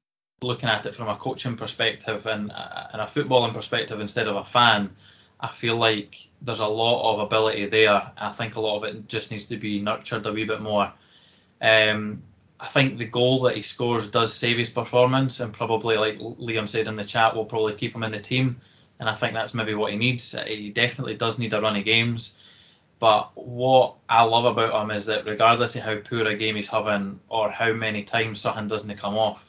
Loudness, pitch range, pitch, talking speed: -23 LUFS, 105-120 Hz, 110 Hz, 220 wpm